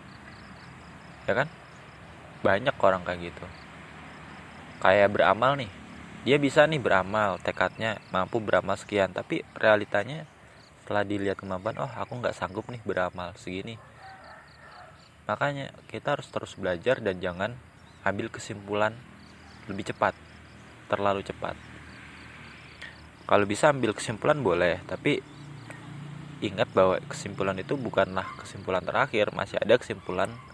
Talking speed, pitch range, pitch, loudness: 110 wpm, 95-125 Hz, 105 Hz, -27 LUFS